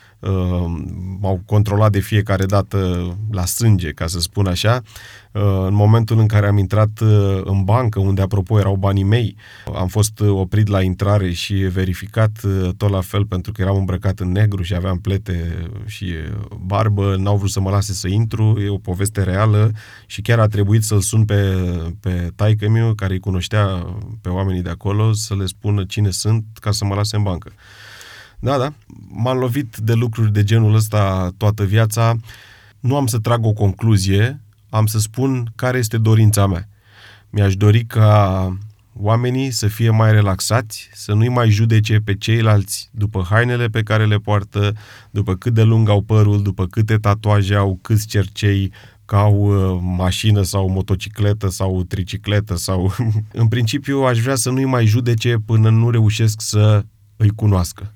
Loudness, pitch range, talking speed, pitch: -17 LUFS, 95-110 Hz, 170 wpm, 105 Hz